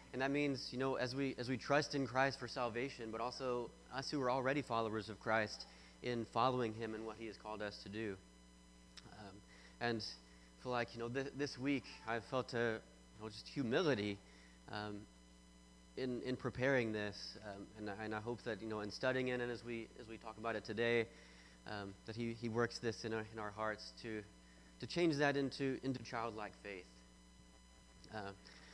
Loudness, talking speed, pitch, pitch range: -42 LUFS, 200 wpm, 110 Hz, 90-125 Hz